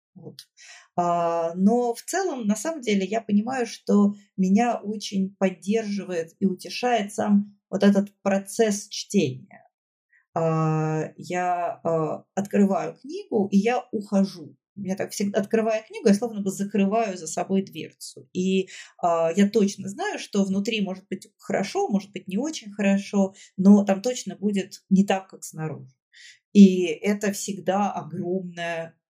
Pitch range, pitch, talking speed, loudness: 180-215 Hz, 195 Hz, 130 wpm, -24 LUFS